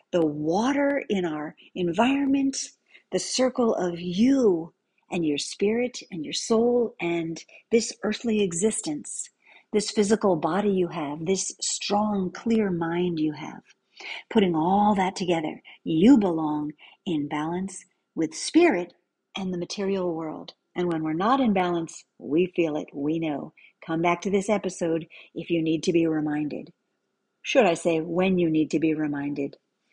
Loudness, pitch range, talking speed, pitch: -25 LUFS, 160-210 Hz, 150 wpm, 180 Hz